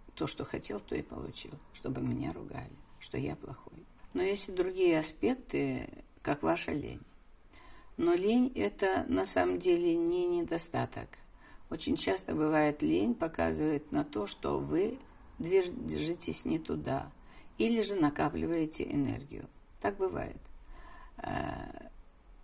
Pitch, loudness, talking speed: 170 Hz, -33 LUFS, 125 wpm